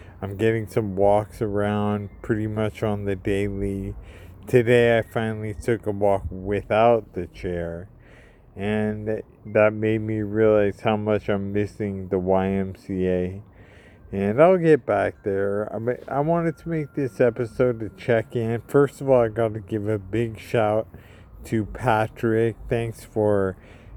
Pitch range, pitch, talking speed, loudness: 100-115 Hz, 105 Hz, 145 wpm, -23 LUFS